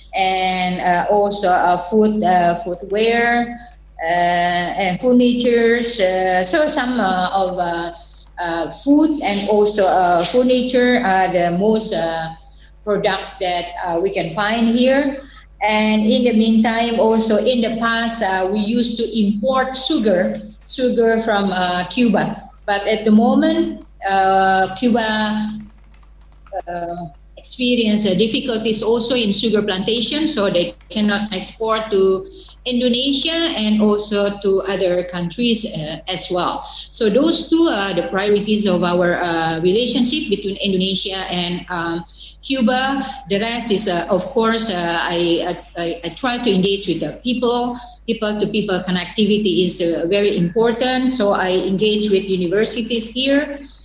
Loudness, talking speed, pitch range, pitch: -17 LUFS, 140 wpm, 180-235 Hz, 205 Hz